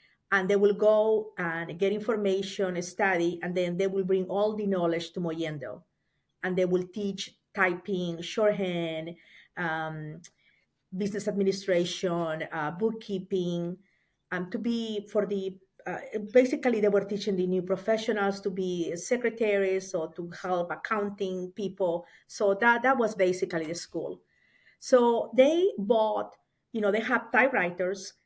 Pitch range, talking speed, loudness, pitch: 175-210 Hz, 140 wpm, -28 LUFS, 195 Hz